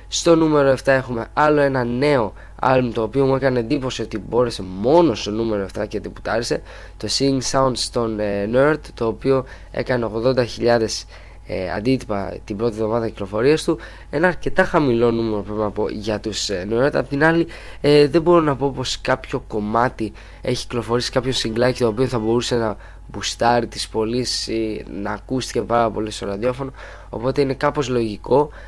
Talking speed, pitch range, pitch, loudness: 175 wpm, 110-135 Hz, 120 Hz, -20 LUFS